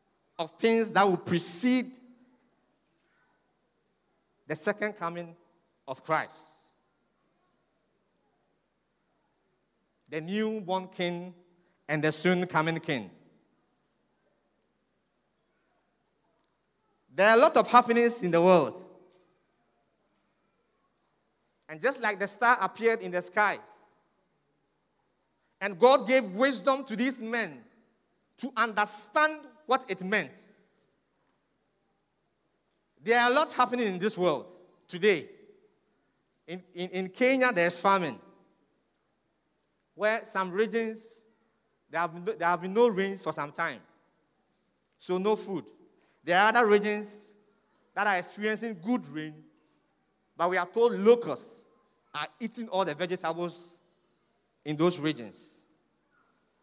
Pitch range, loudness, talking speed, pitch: 175-230 Hz, -27 LUFS, 110 wpm, 200 Hz